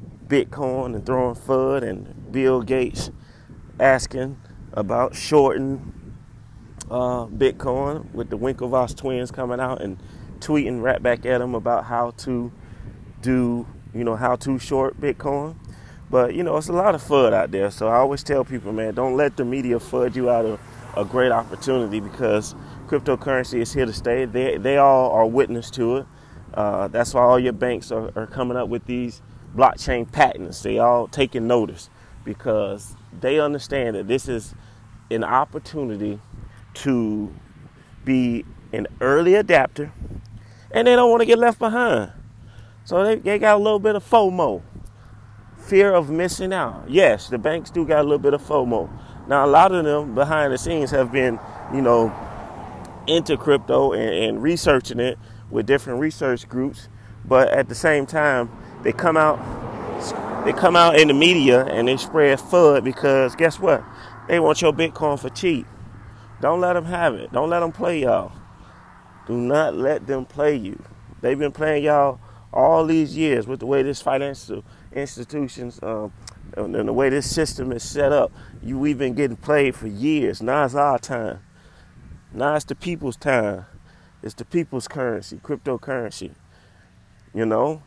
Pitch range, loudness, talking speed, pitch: 115-145 Hz, -20 LUFS, 170 wpm, 125 Hz